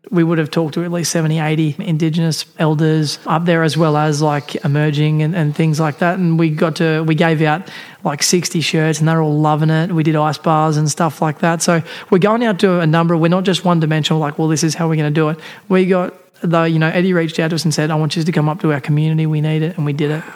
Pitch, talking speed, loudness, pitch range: 160 Hz, 285 wpm, -15 LUFS, 155-170 Hz